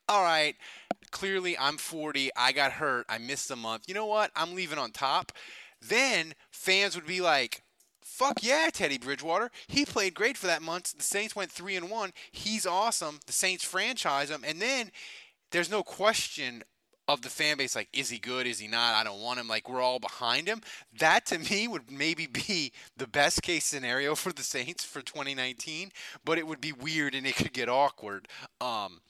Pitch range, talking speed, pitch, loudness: 135-190 Hz, 200 wpm, 155 Hz, -30 LUFS